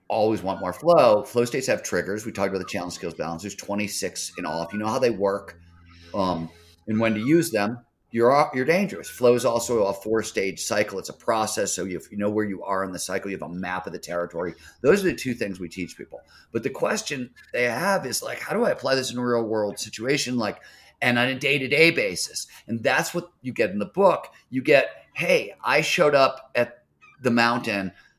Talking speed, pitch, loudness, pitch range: 230 wpm, 110 Hz, -24 LUFS, 95-120 Hz